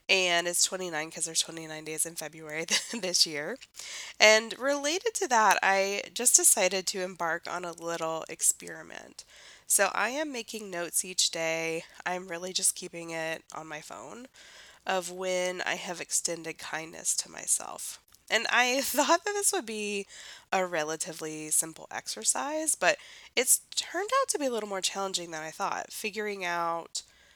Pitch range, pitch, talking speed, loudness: 165-230 Hz, 185 Hz, 160 wpm, -28 LUFS